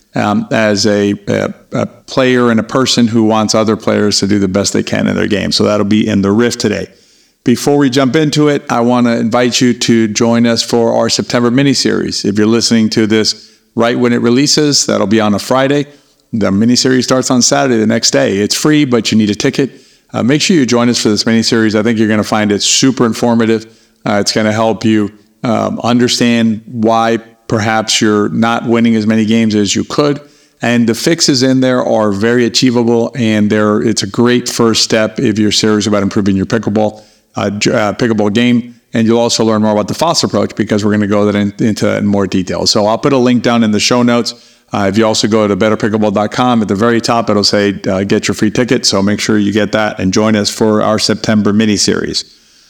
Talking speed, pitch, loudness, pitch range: 230 wpm, 115 Hz, -11 LUFS, 105-120 Hz